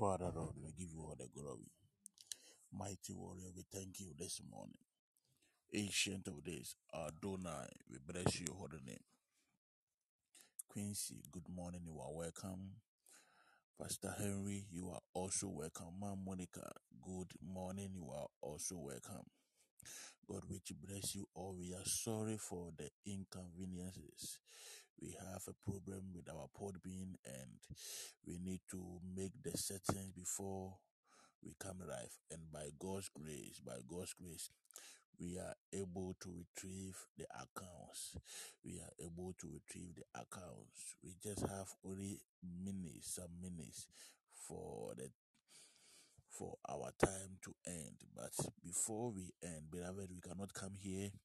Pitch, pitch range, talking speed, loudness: 95 Hz, 90-100 Hz, 140 wpm, -49 LUFS